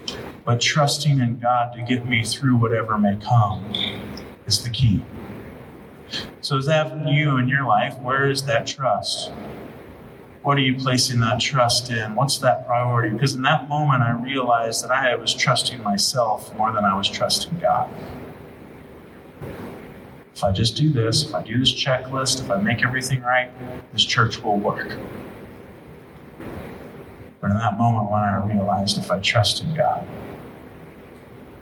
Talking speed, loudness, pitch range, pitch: 160 wpm, -21 LUFS, 110-130 Hz, 125 Hz